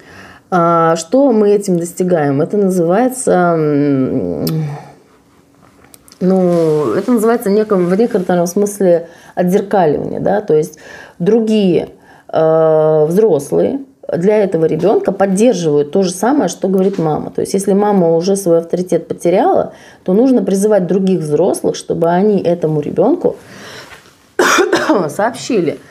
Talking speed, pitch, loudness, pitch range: 105 wpm, 185 Hz, -13 LUFS, 160-205 Hz